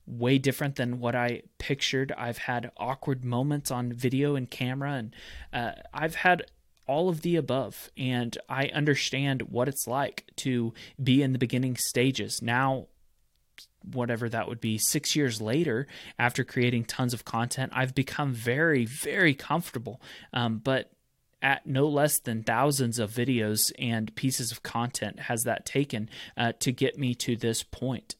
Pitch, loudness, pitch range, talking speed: 125 Hz, -28 LUFS, 120-135 Hz, 160 wpm